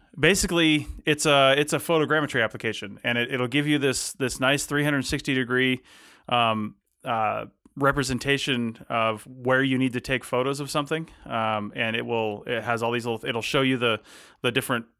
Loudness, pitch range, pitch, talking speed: -24 LUFS, 115-145 Hz, 130 Hz, 190 wpm